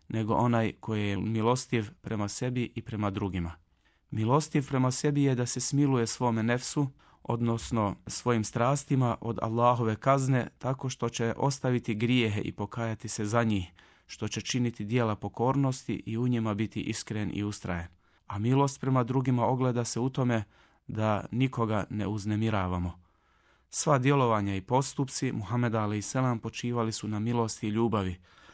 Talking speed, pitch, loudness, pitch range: 150 wpm, 115 Hz, -29 LUFS, 105-125 Hz